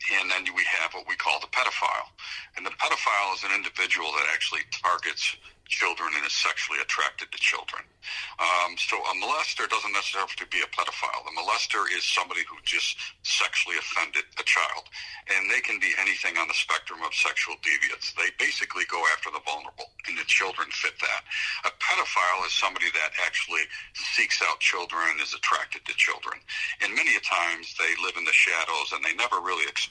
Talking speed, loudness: 195 wpm, -25 LUFS